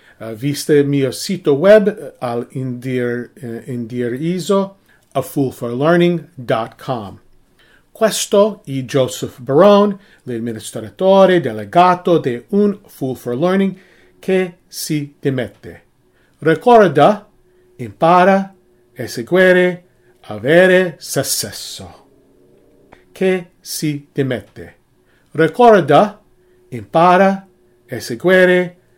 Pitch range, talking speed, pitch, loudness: 120-185 Hz, 75 wpm, 145 Hz, -15 LUFS